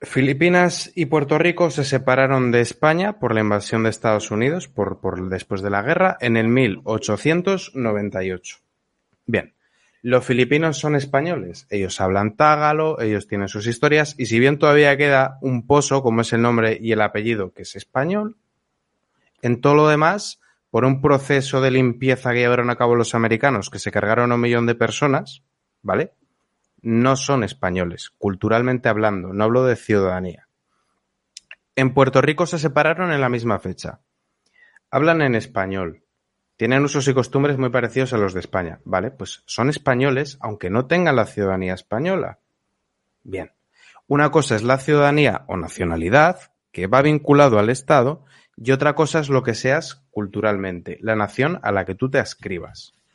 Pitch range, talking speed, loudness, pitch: 110-145 Hz, 165 wpm, -19 LUFS, 125 Hz